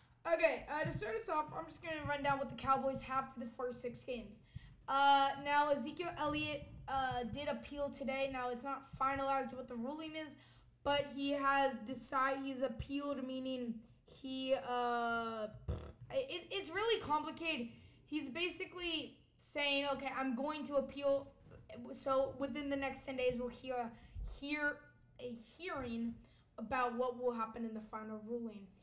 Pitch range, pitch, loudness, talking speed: 250-290 Hz, 270 Hz, -39 LUFS, 160 wpm